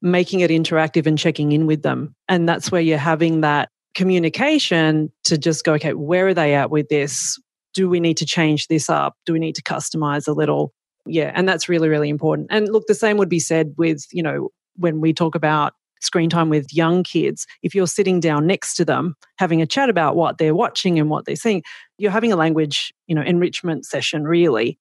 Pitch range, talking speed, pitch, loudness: 155-180 Hz, 220 wpm, 165 Hz, -19 LUFS